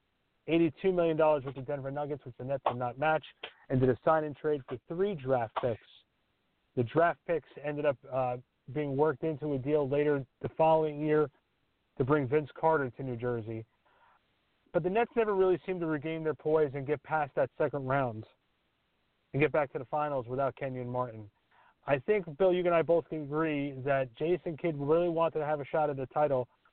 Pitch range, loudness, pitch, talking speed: 135-160 Hz, -31 LUFS, 150 Hz, 200 wpm